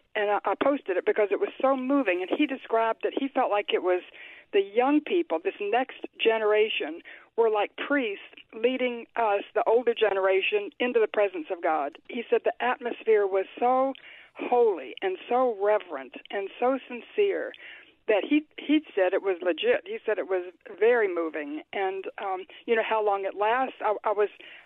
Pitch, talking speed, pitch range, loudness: 245 Hz, 185 wpm, 210-340 Hz, -27 LUFS